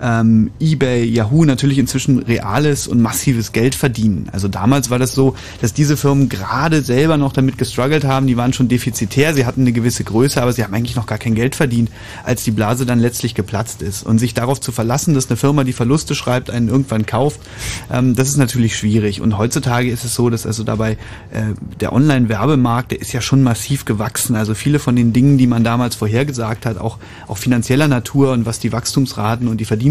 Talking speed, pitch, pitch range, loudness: 215 wpm, 120 Hz, 110-135 Hz, -16 LUFS